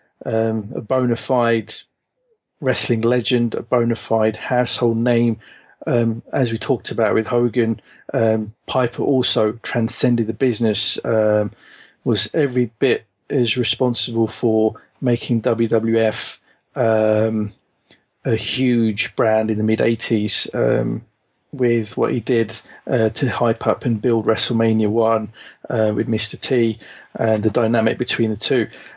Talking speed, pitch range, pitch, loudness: 130 wpm, 110-120 Hz, 115 Hz, -19 LUFS